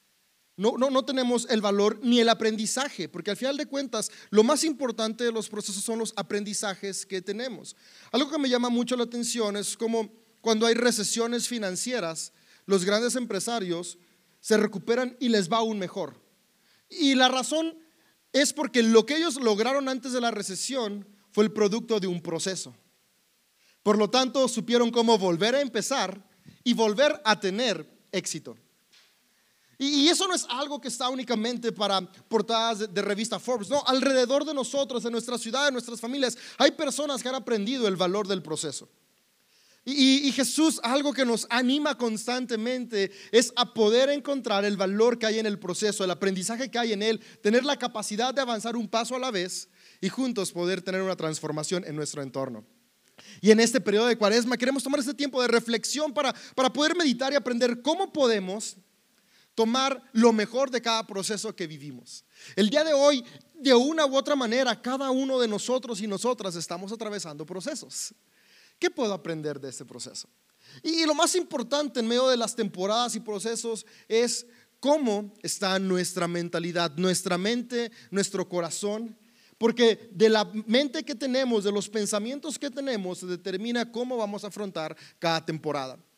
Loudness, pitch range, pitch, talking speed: -26 LUFS, 200-255 Hz, 230 Hz, 175 wpm